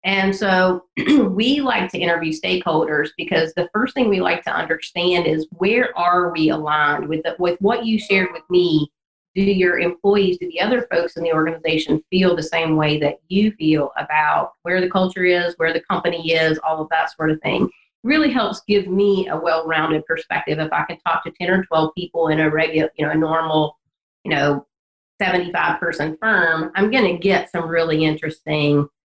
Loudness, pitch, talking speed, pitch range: -19 LUFS, 170 Hz, 195 wpm, 160-185 Hz